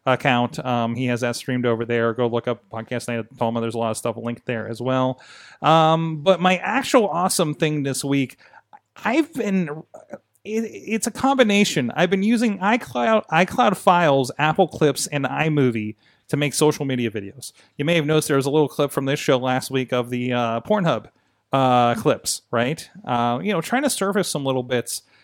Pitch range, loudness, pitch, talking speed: 120-185 Hz, -21 LUFS, 140 Hz, 195 wpm